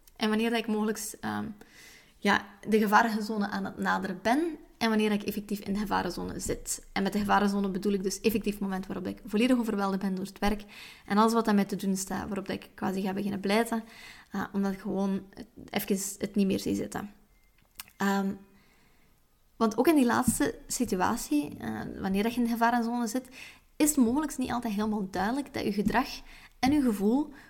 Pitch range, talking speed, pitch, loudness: 195-235 Hz, 200 wpm, 215 Hz, -29 LUFS